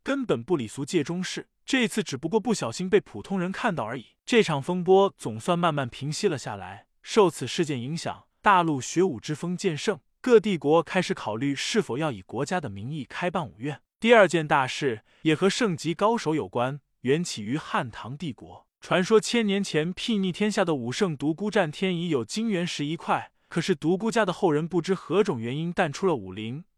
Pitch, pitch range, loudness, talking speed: 175 Hz, 145-195 Hz, -26 LUFS, 300 characters per minute